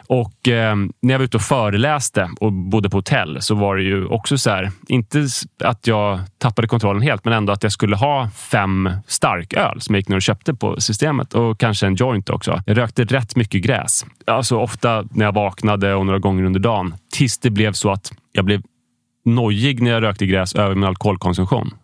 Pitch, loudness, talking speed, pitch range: 110 Hz, -18 LUFS, 210 wpm, 100-125 Hz